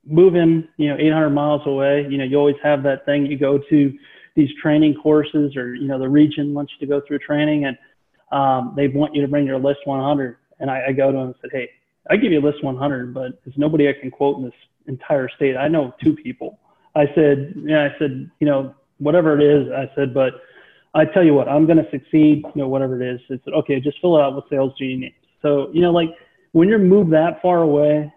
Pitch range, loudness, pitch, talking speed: 135-155 Hz, -18 LUFS, 145 Hz, 245 wpm